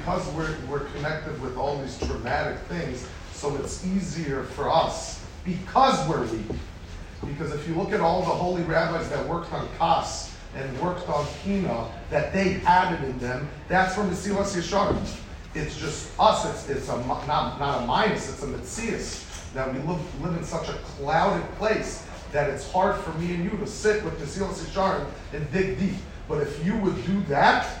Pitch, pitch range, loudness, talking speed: 175 Hz, 145-190 Hz, -26 LUFS, 190 wpm